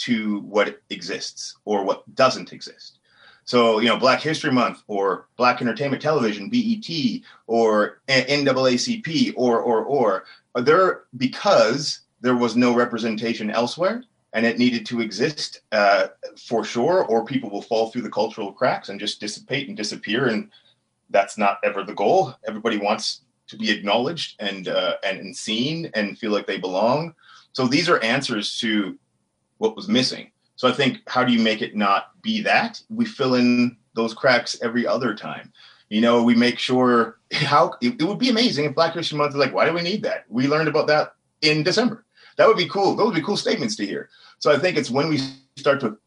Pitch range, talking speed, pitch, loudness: 115-165 Hz, 190 wpm, 130 Hz, -21 LUFS